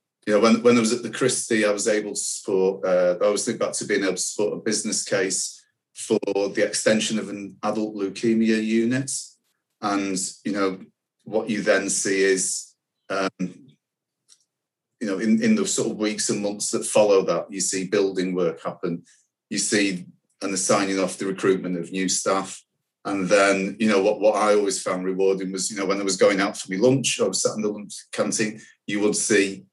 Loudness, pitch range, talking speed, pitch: -23 LUFS, 95-110 Hz, 210 wpm, 100 Hz